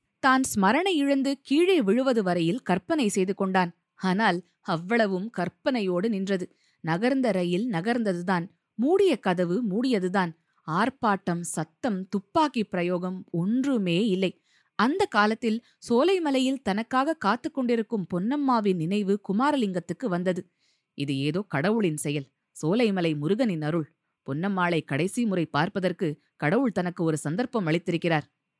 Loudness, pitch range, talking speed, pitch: -26 LUFS, 175-235 Hz, 105 wpm, 195 Hz